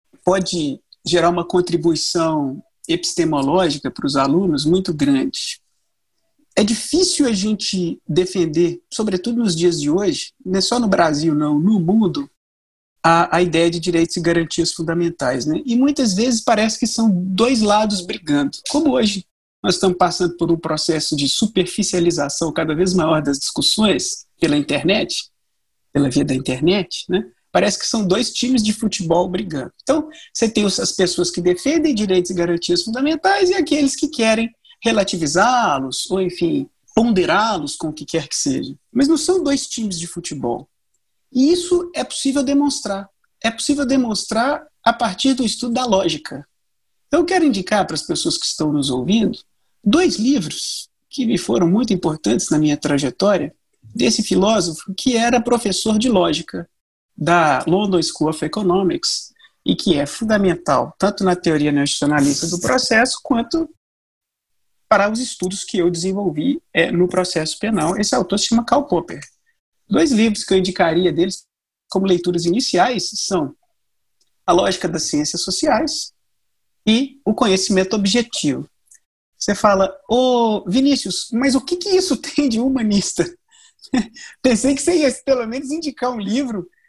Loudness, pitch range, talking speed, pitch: -18 LUFS, 175-255 Hz, 155 wpm, 200 Hz